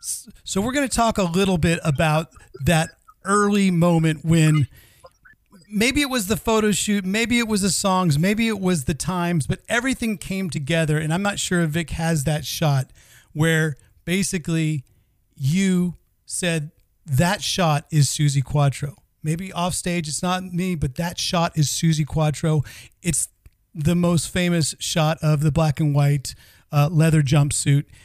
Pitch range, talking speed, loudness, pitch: 150-185 Hz, 160 wpm, -21 LUFS, 165 Hz